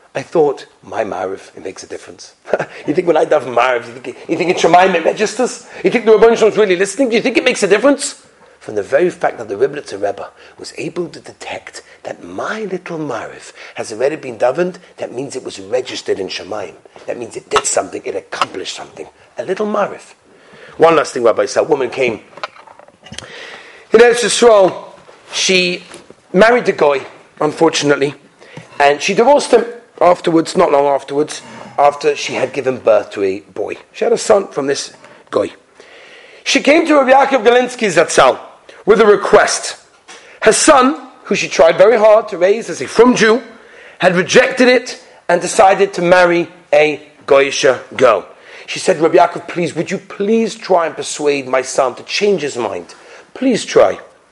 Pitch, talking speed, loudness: 215 Hz, 185 wpm, -13 LUFS